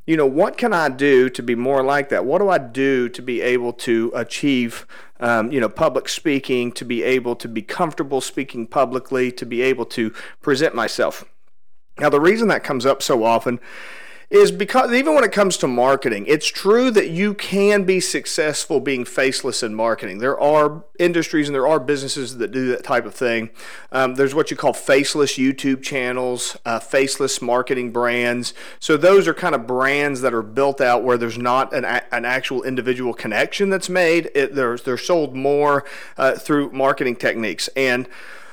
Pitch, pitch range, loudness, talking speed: 135 Hz, 125-155 Hz, -19 LUFS, 190 wpm